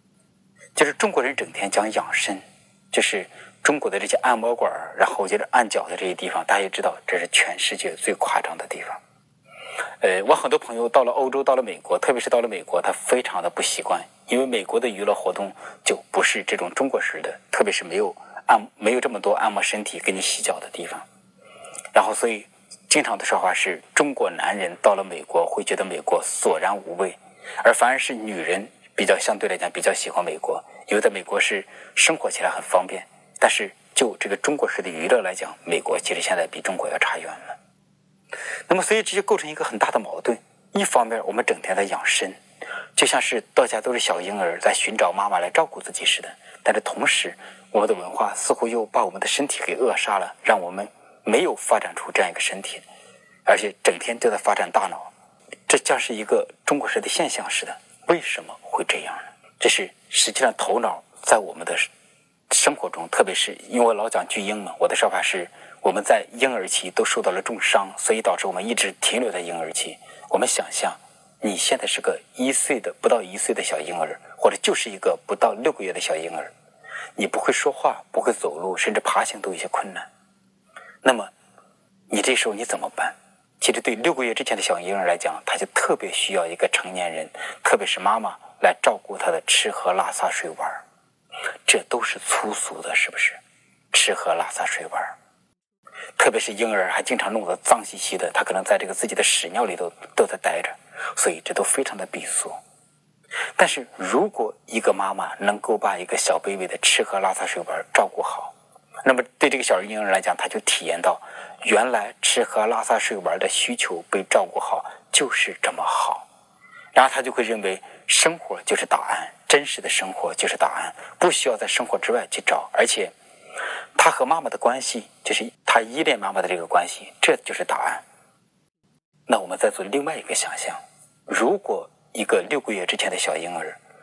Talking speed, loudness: 300 characters per minute, -22 LUFS